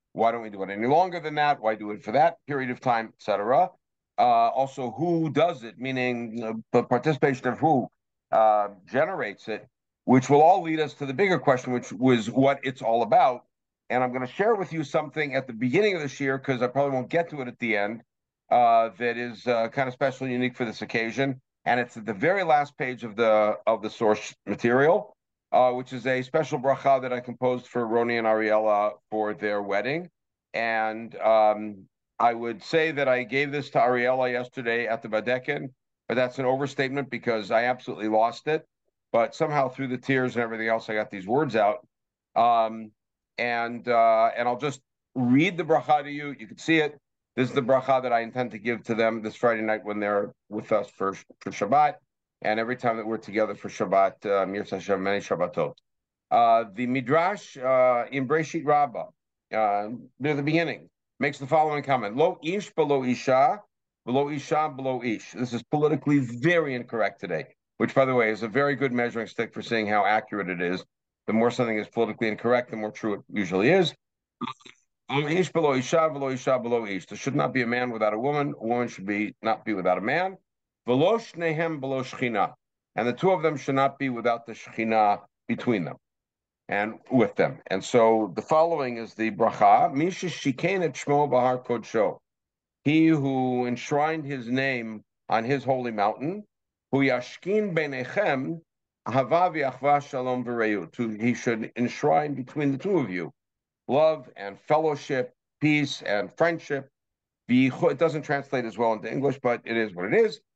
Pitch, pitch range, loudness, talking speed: 125 Hz, 115-145 Hz, -25 LUFS, 180 wpm